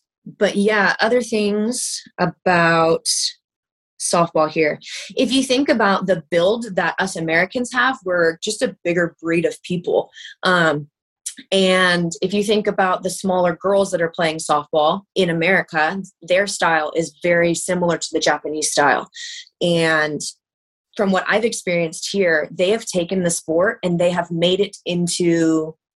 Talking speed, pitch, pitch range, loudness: 150 wpm, 180 Hz, 165-200 Hz, -18 LUFS